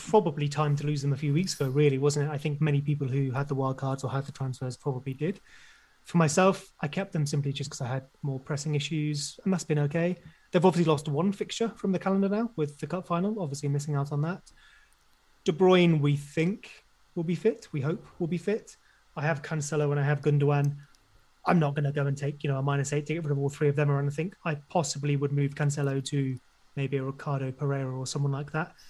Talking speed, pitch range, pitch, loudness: 240 wpm, 140-170 Hz, 150 Hz, -29 LUFS